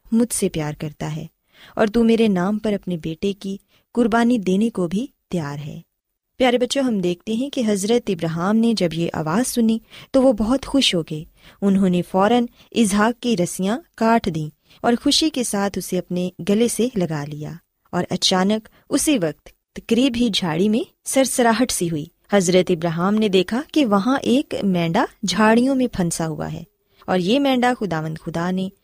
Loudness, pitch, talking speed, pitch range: -20 LUFS, 205 Hz, 115 wpm, 180-235 Hz